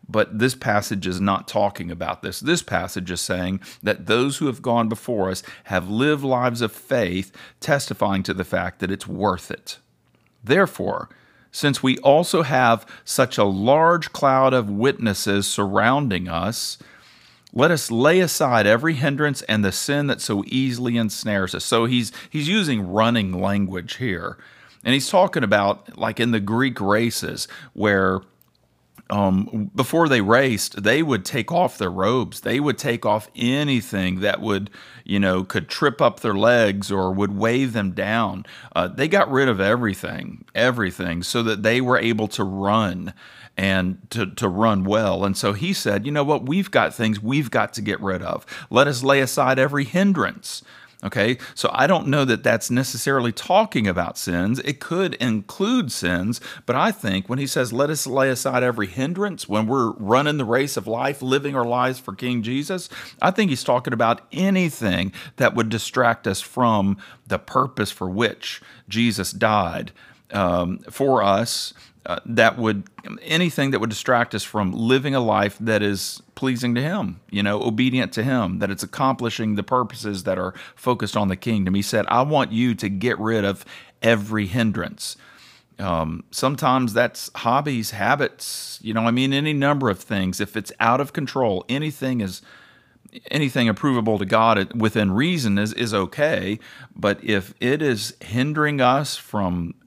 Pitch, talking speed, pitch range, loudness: 115 Hz, 170 wpm, 100-130 Hz, -21 LUFS